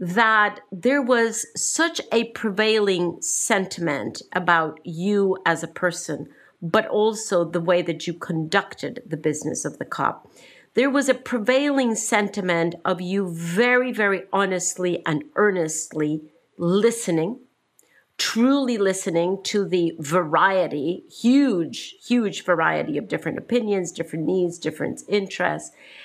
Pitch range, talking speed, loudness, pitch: 170-225 Hz, 120 wpm, -22 LUFS, 190 Hz